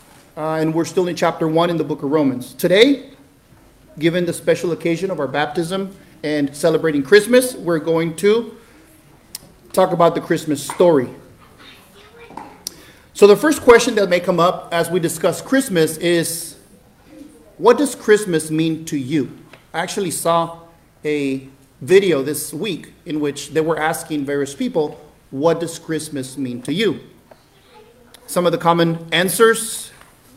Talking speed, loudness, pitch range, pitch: 150 wpm, -18 LUFS, 155-185 Hz, 165 Hz